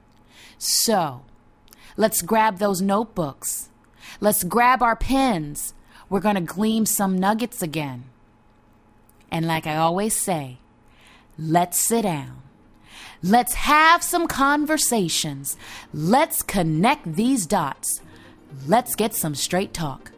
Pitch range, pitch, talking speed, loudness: 135-220 Hz, 180 Hz, 110 wpm, -21 LUFS